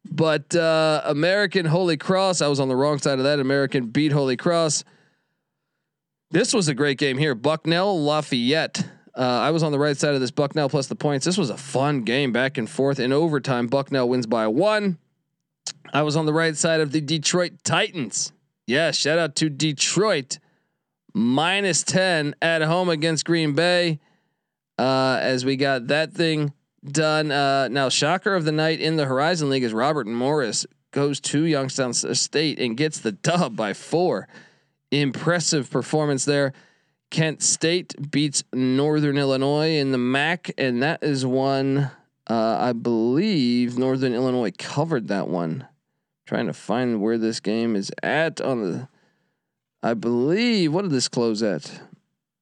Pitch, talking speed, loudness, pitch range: 145 Hz, 165 wpm, -22 LUFS, 135-160 Hz